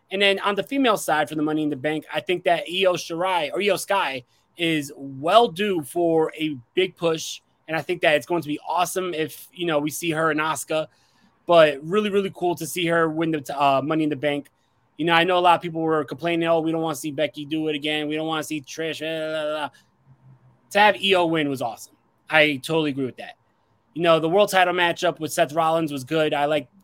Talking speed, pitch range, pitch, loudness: 255 wpm, 150-175 Hz, 160 Hz, -22 LUFS